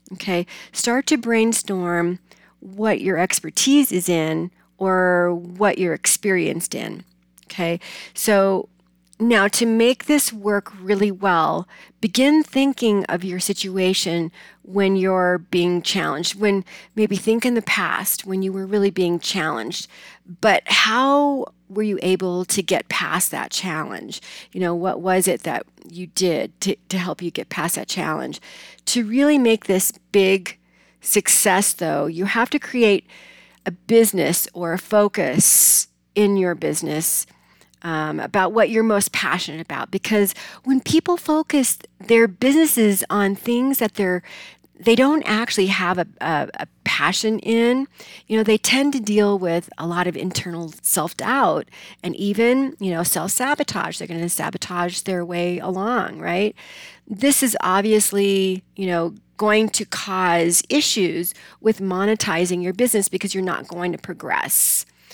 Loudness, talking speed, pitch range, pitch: -19 LUFS, 150 wpm, 180-220 Hz, 195 Hz